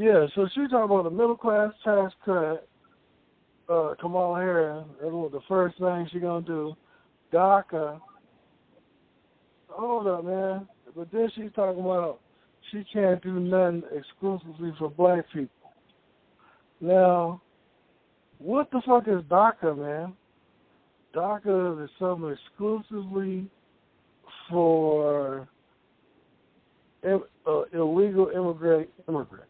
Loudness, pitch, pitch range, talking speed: -26 LUFS, 180 Hz, 160-200 Hz, 110 wpm